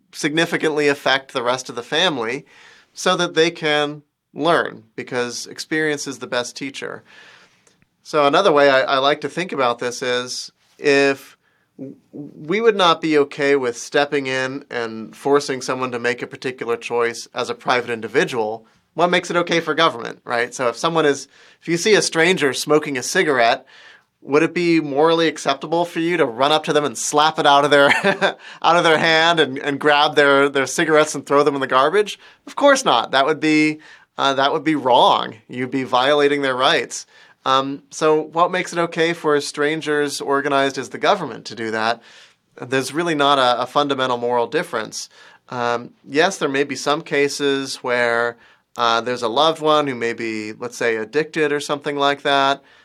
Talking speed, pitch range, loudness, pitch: 185 wpm, 130-155 Hz, -18 LUFS, 145 Hz